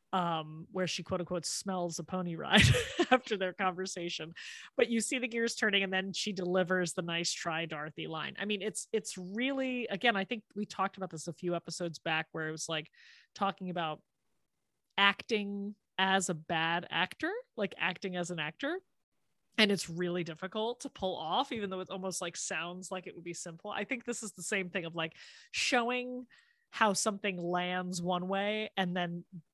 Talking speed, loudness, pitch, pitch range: 190 wpm, -34 LUFS, 190 Hz, 175-215 Hz